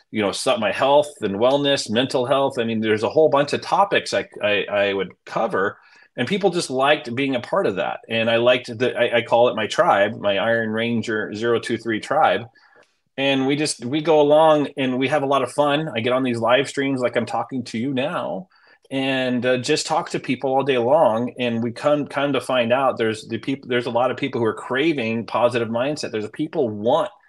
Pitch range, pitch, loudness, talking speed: 115-140 Hz, 125 Hz, -20 LUFS, 225 wpm